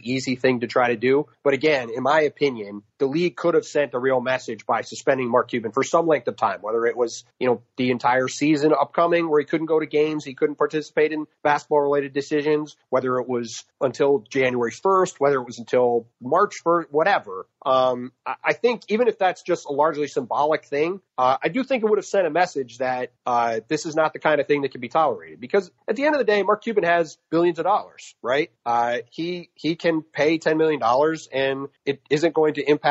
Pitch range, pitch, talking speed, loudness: 130-165 Hz, 150 Hz, 225 wpm, -22 LUFS